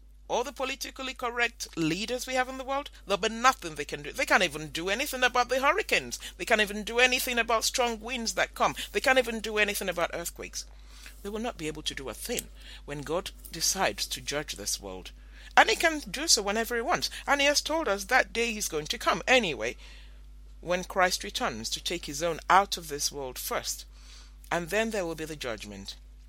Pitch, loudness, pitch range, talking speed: 200 Hz, -28 LUFS, 155-250 Hz, 220 wpm